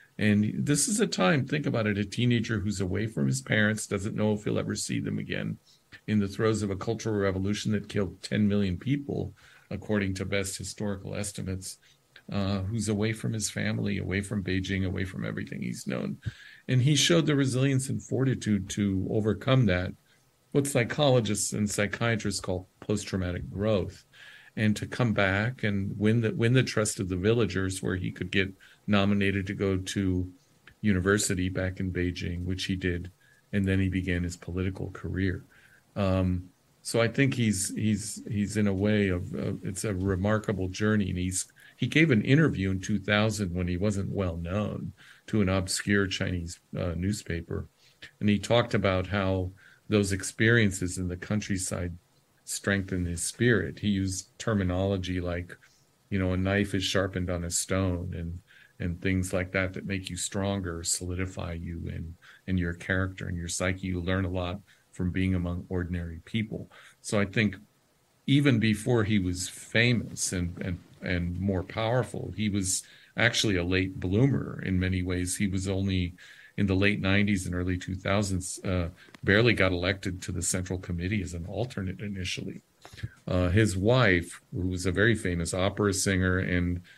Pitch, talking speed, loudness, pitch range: 100 Hz, 170 wpm, -28 LUFS, 90-105 Hz